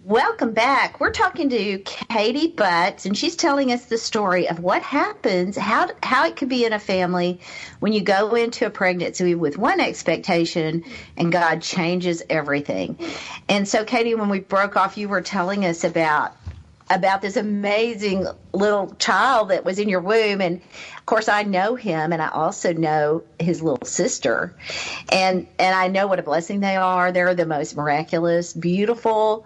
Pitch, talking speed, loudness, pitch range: 185 Hz, 175 wpm, -21 LUFS, 170-215 Hz